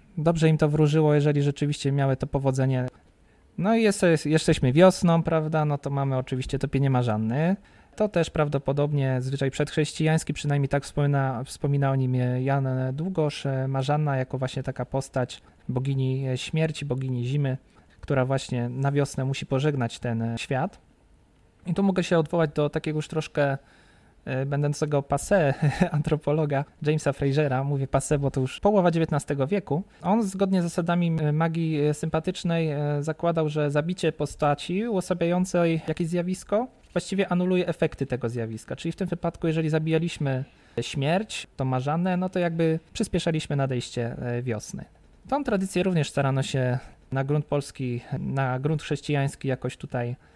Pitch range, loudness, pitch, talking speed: 135-165 Hz, -26 LUFS, 145 Hz, 140 wpm